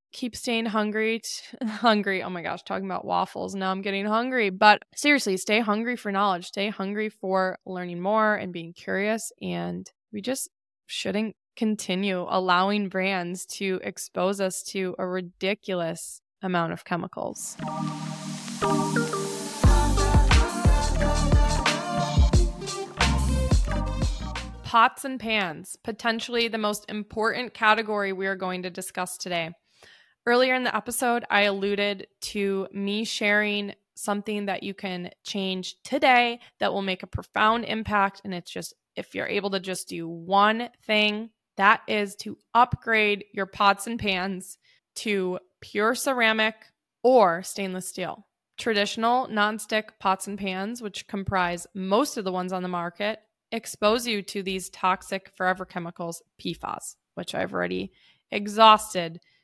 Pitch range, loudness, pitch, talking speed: 185-220 Hz, -26 LUFS, 200 Hz, 130 wpm